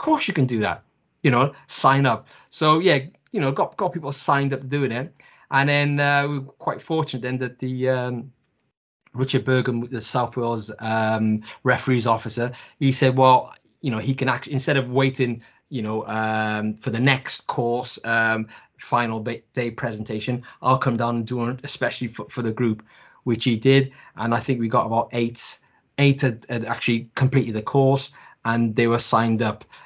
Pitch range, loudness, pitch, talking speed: 115-135 Hz, -22 LUFS, 125 Hz, 190 wpm